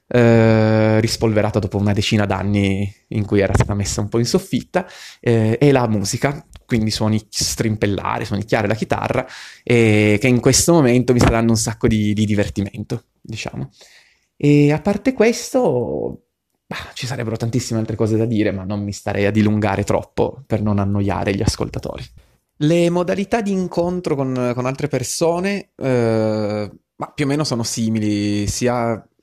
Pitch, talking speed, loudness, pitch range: 115 Hz, 165 wpm, -18 LUFS, 105-130 Hz